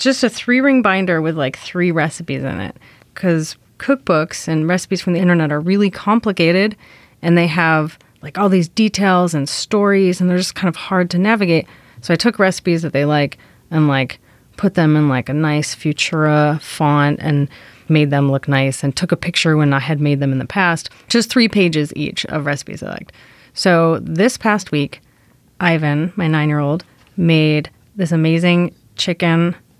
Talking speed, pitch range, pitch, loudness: 185 wpm, 150-185 Hz, 165 Hz, -16 LUFS